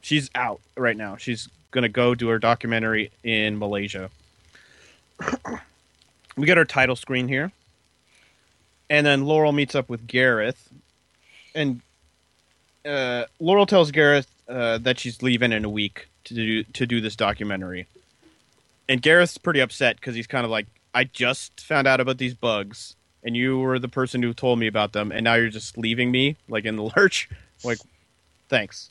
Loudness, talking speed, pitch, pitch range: -22 LUFS, 170 wpm, 120 Hz, 110-130 Hz